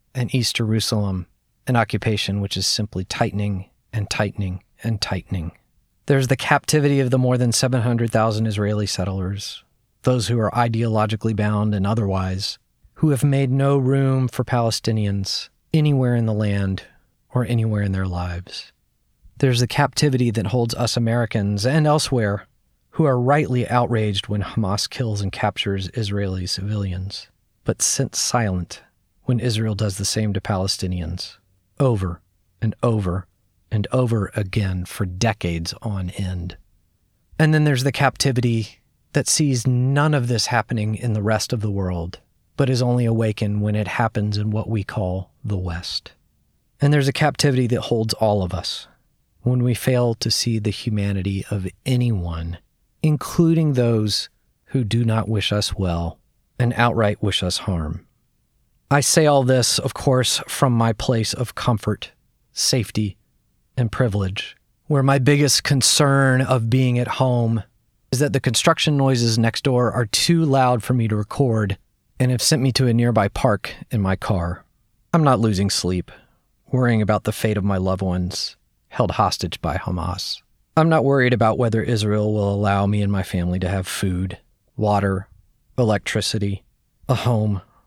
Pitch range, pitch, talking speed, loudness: 100-125 Hz, 110 Hz, 155 wpm, -21 LUFS